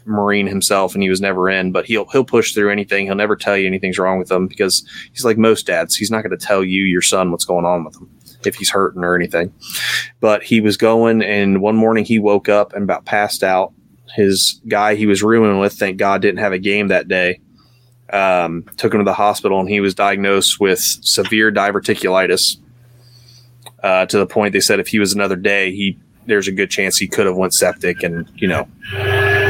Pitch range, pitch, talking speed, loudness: 95-110 Hz, 100 Hz, 220 wpm, -15 LUFS